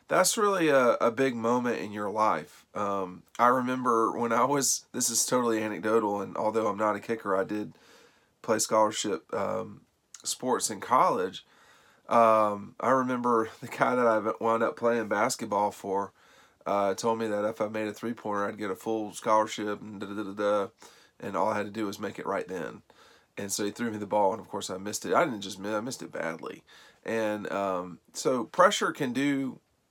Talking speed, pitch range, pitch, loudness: 200 wpm, 100-115 Hz, 110 Hz, -28 LUFS